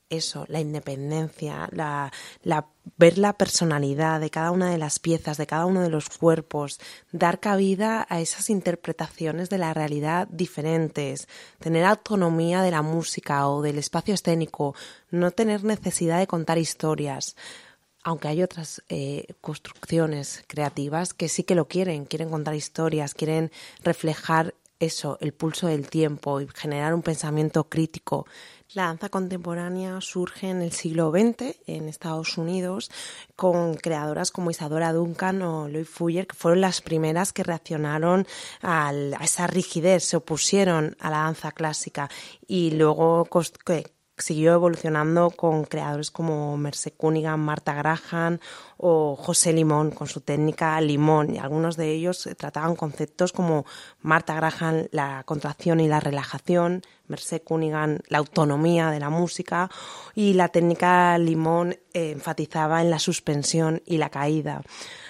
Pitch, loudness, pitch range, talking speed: 165 Hz, -25 LUFS, 155-175 Hz, 145 wpm